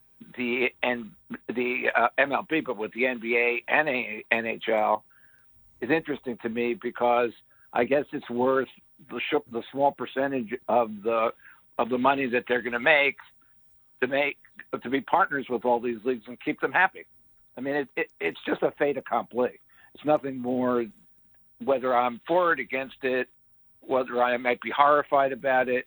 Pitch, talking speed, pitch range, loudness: 125 Hz, 165 wpm, 120-135 Hz, -26 LUFS